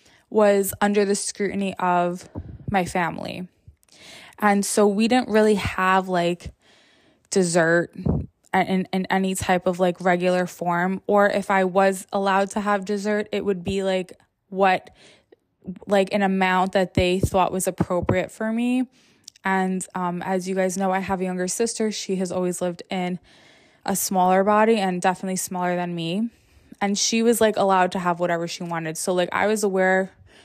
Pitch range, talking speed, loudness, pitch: 180-205 Hz, 170 wpm, -22 LUFS, 190 Hz